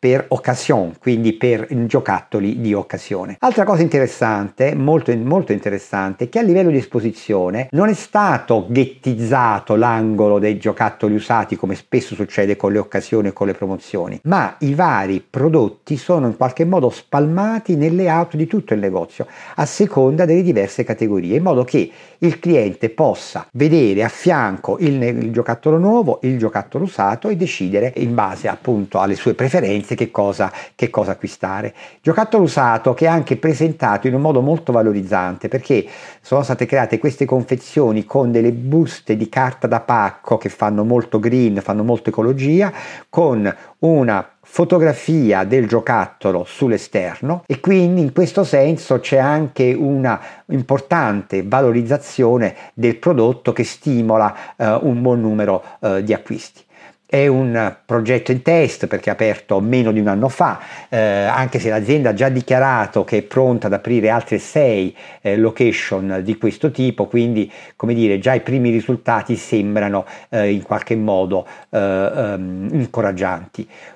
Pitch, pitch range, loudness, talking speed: 125 Hz, 110-150 Hz, -17 LUFS, 155 wpm